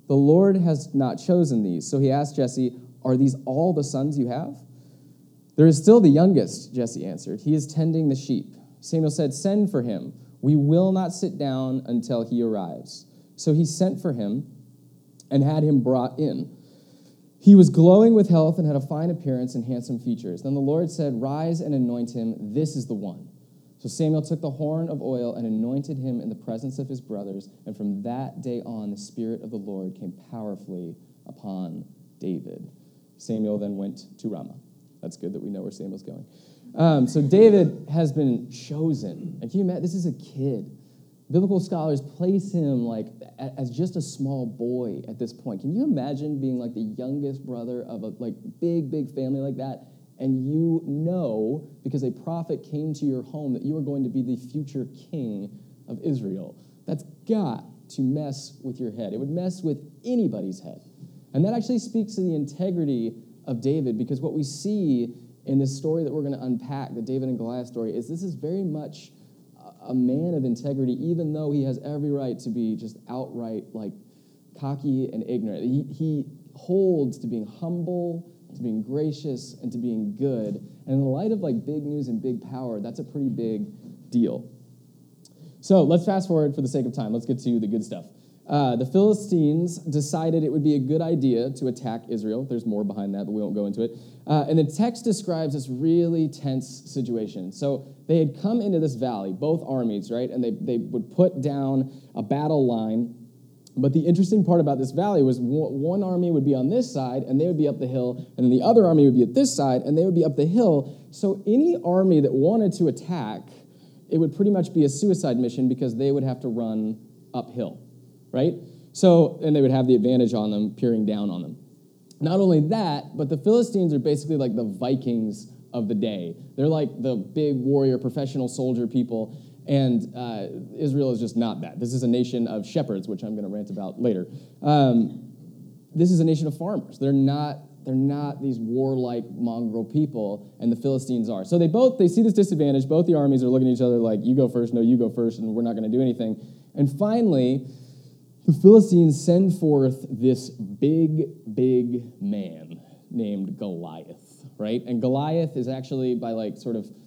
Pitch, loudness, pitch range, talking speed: 140 Hz, -24 LUFS, 125-160 Hz, 200 wpm